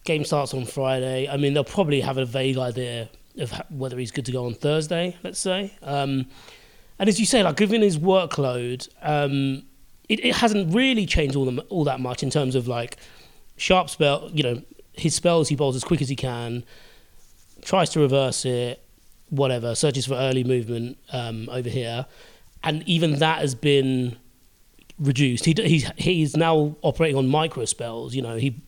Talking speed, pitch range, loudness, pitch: 190 wpm, 125-160 Hz, -23 LUFS, 140 Hz